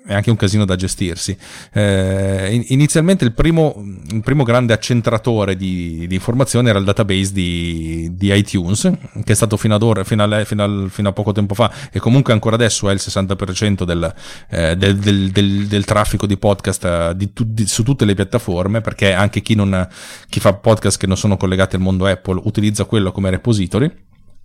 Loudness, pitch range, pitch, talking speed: -16 LUFS, 95-115 Hz, 100 Hz, 190 wpm